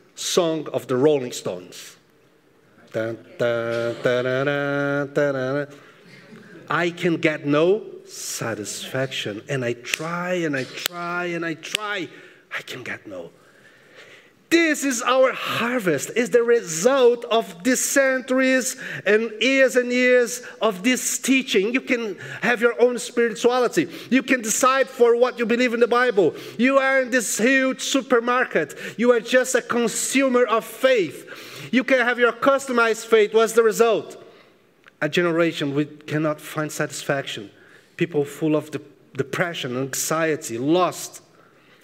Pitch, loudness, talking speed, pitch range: 225 Hz, -21 LUFS, 130 wpm, 155-255 Hz